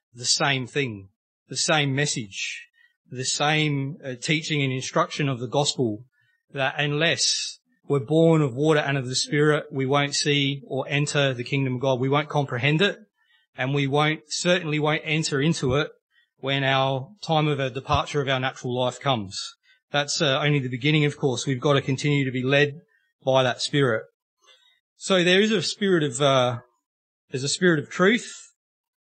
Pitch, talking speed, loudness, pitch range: 145 Hz, 175 wpm, -23 LUFS, 135-160 Hz